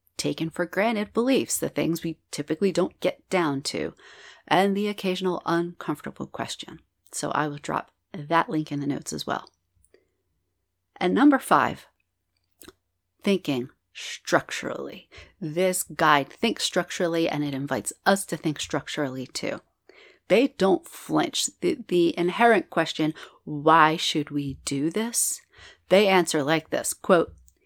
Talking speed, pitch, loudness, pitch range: 135 wpm, 160 Hz, -25 LUFS, 140-185 Hz